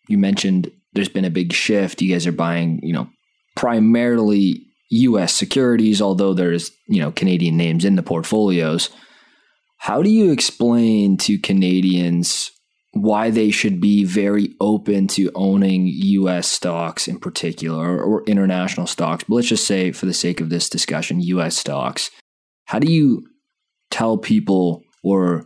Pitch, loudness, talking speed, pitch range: 100 Hz, -18 LUFS, 155 wpm, 90-115 Hz